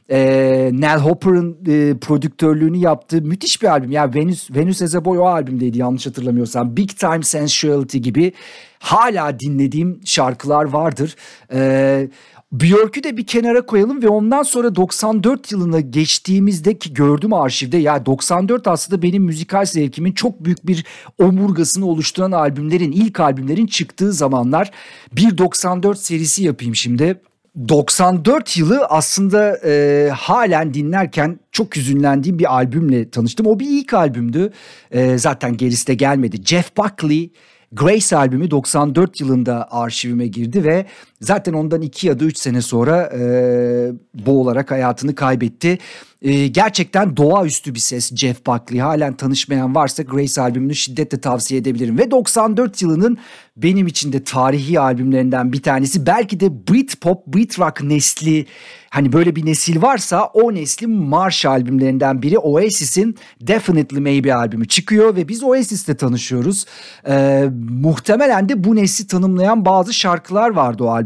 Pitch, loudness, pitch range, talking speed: 155 Hz, -15 LUFS, 135-190 Hz, 140 wpm